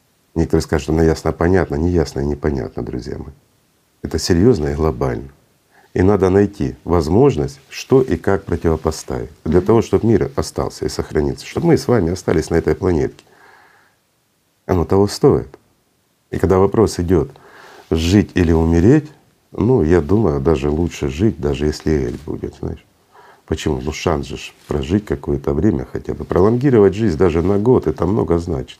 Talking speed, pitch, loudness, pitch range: 160 wpm, 85 Hz, -17 LUFS, 75-95 Hz